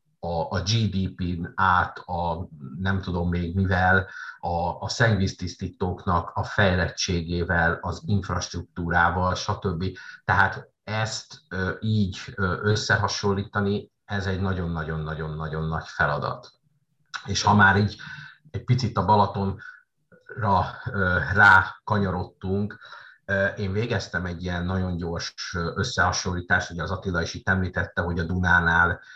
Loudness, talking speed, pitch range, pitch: -24 LUFS, 100 wpm, 85-100 Hz, 95 Hz